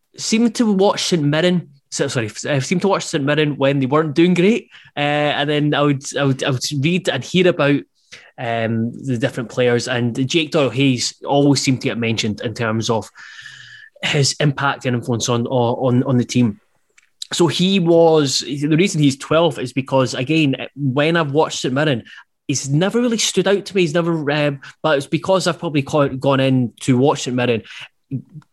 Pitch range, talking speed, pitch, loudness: 130-165 Hz, 195 wpm, 145 Hz, -18 LUFS